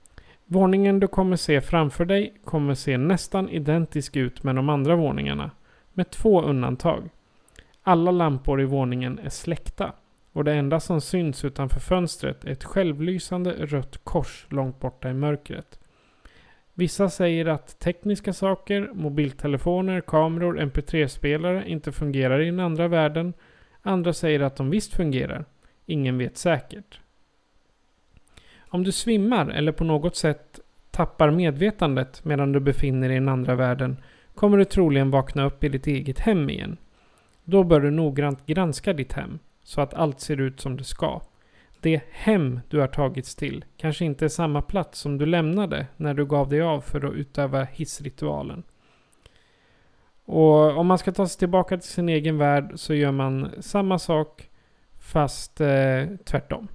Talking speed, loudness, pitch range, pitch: 155 wpm, -24 LUFS, 140-175 Hz, 155 Hz